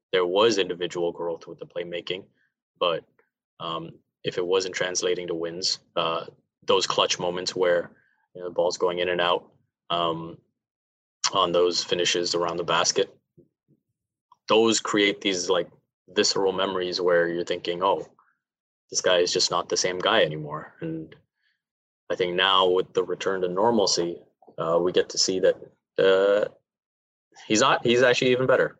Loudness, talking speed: -24 LUFS, 160 wpm